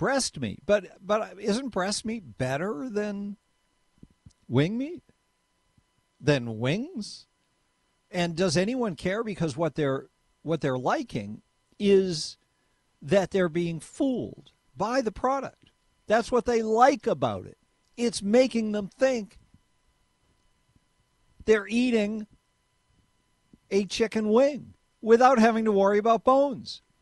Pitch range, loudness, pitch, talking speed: 180-235 Hz, -26 LUFS, 210 Hz, 115 wpm